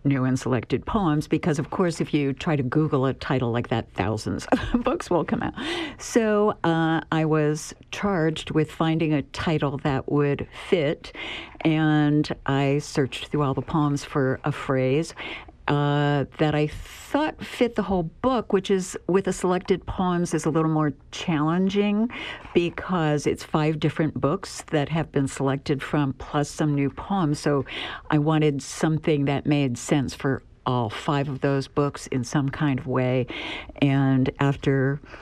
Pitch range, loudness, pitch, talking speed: 135-160 Hz, -24 LUFS, 150 Hz, 165 wpm